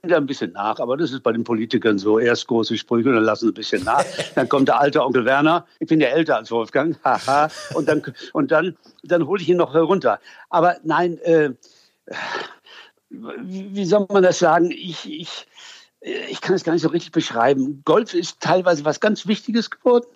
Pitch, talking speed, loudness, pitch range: 170 Hz, 200 wpm, -19 LUFS, 140-200 Hz